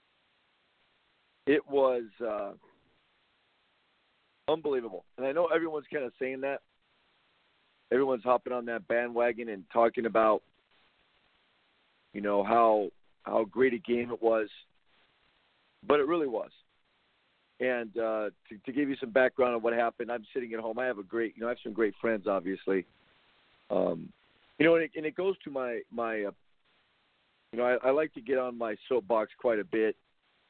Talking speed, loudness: 165 wpm, -30 LUFS